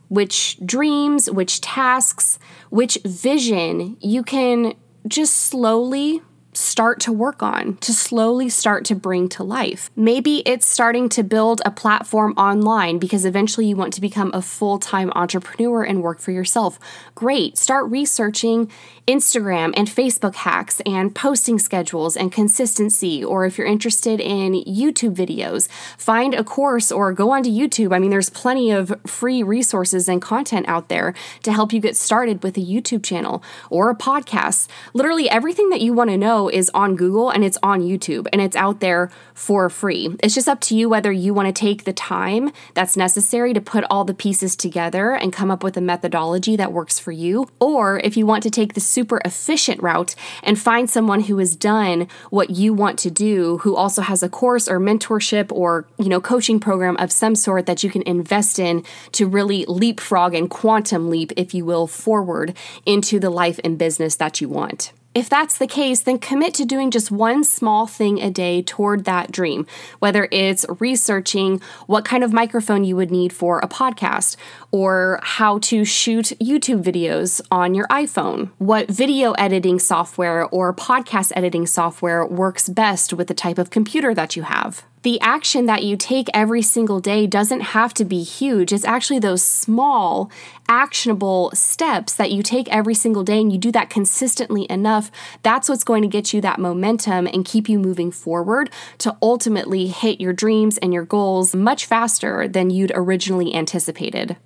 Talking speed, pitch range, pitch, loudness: 180 wpm, 185-230 Hz, 205 Hz, -18 LUFS